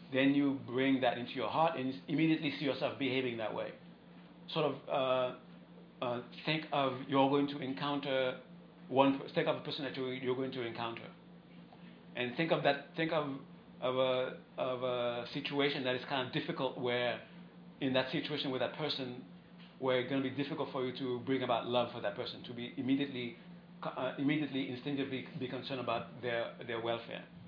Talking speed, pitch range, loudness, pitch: 190 wpm, 125-145 Hz, -36 LUFS, 135 Hz